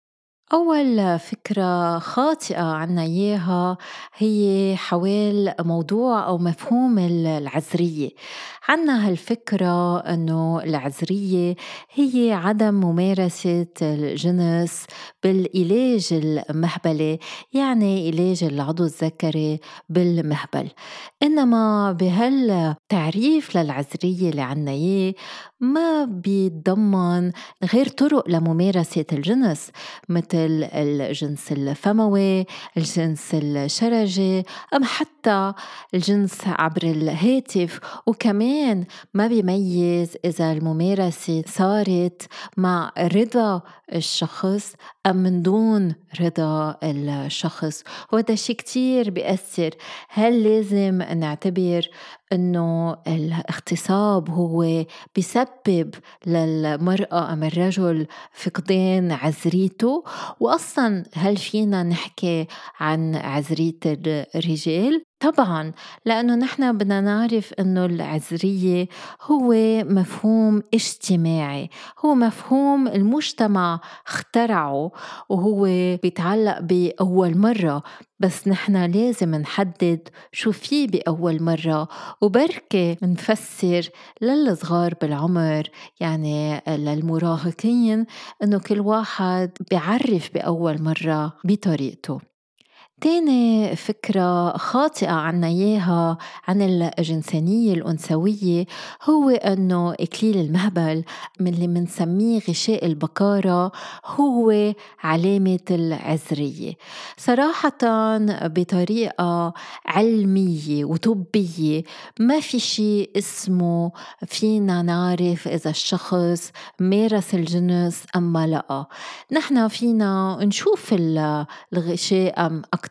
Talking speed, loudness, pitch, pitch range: 80 wpm, -21 LUFS, 185 Hz, 165-215 Hz